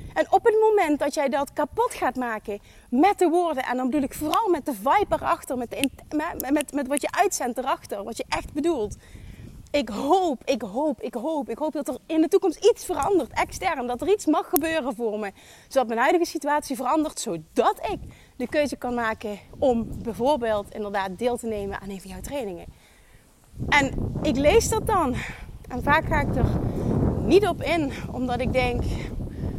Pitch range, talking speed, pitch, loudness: 245-340 Hz, 195 wpm, 290 Hz, -24 LUFS